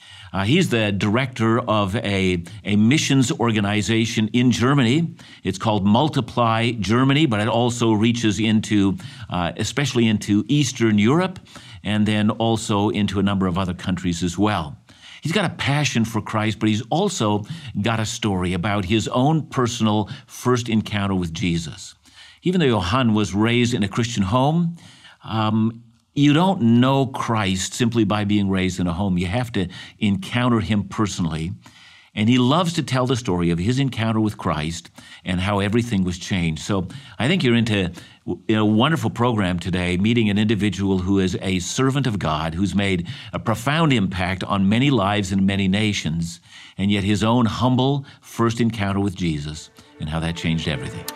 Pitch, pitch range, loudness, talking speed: 110 Hz, 95-120 Hz, -20 LUFS, 170 wpm